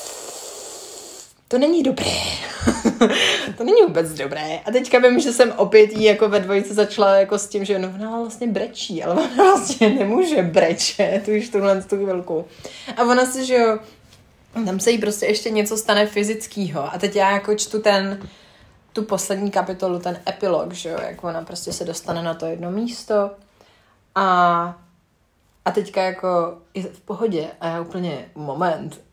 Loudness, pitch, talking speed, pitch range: -19 LUFS, 200 Hz, 170 wpm, 175-225 Hz